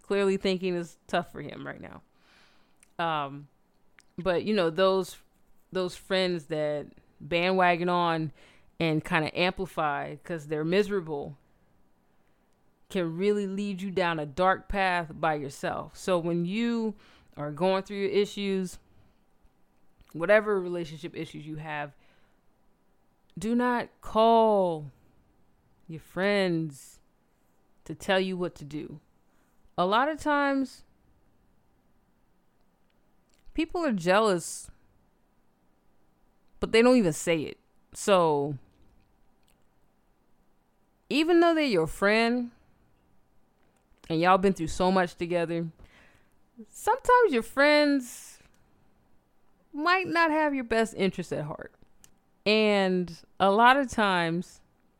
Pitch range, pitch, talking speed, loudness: 160-210 Hz, 185 Hz, 110 wpm, -27 LUFS